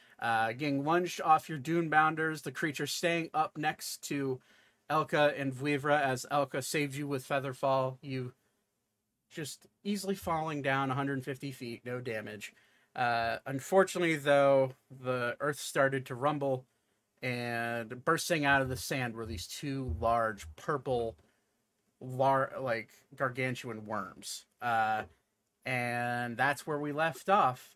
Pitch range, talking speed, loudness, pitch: 125-150 Hz, 130 wpm, -32 LUFS, 135 Hz